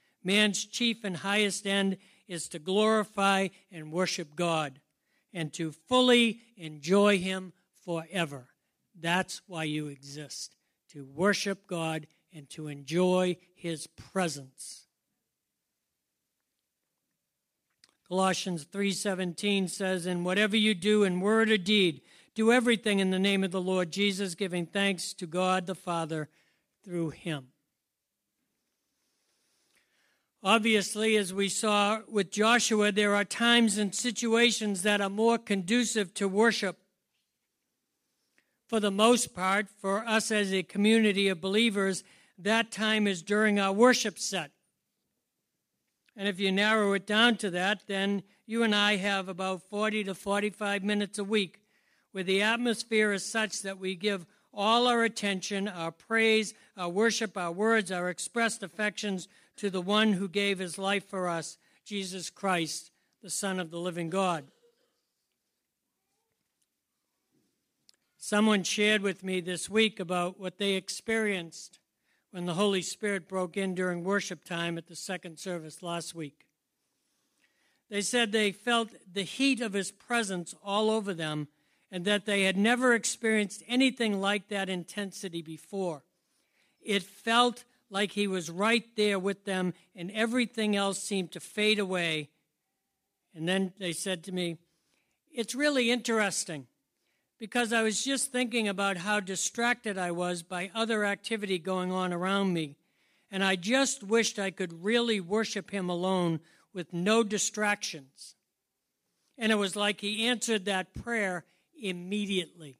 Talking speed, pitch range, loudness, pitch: 140 wpm, 180-215 Hz, -29 LUFS, 200 Hz